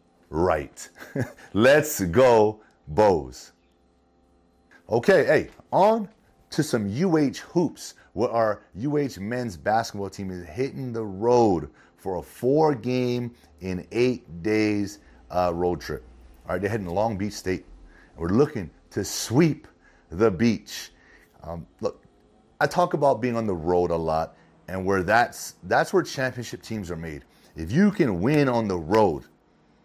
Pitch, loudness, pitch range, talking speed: 105 Hz, -24 LUFS, 85-125 Hz, 145 wpm